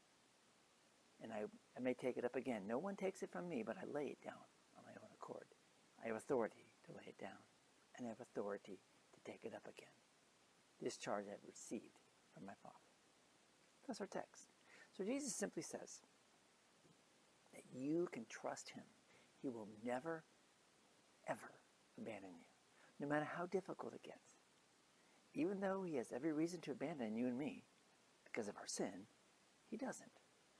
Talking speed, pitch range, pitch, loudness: 165 wpm, 135-200 Hz, 165 Hz, -48 LUFS